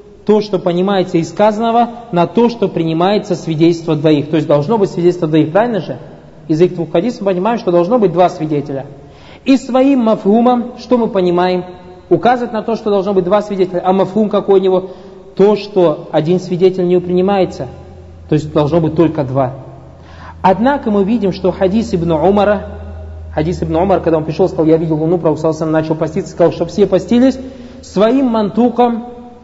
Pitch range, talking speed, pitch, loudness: 160-210 Hz, 175 wpm, 180 Hz, -13 LUFS